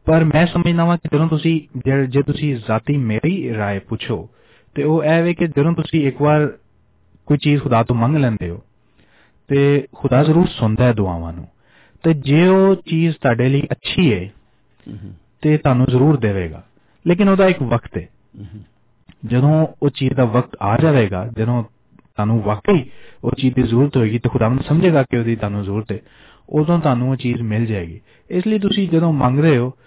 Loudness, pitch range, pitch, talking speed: -17 LUFS, 115-155 Hz, 130 Hz, 185 wpm